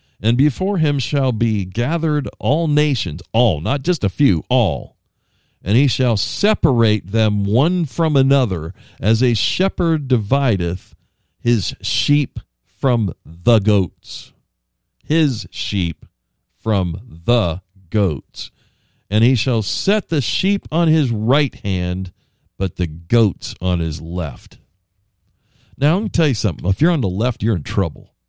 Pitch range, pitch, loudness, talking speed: 95-140 Hz, 115 Hz, -18 LUFS, 140 wpm